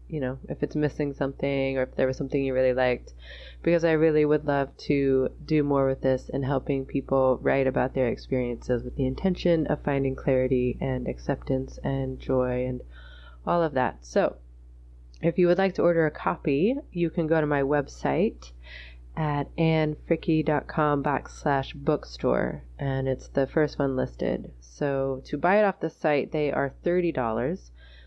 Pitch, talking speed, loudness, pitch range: 135 Hz, 170 wpm, -26 LUFS, 130-150 Hz